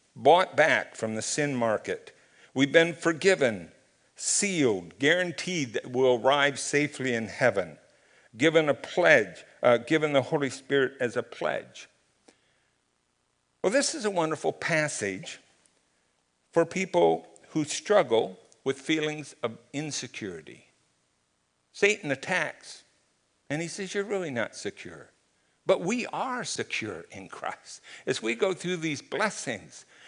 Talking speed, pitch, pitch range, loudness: 125 wpm, 145 Hz, 120-165 Hz, -27 LUFS